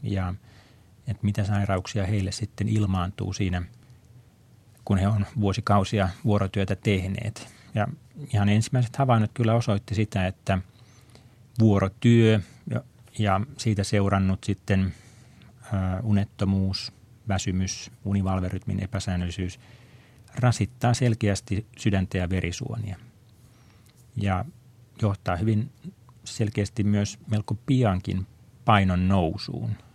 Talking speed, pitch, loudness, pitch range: 90 wpm, 105 Hz, -26 LUFS, 100-120 Hz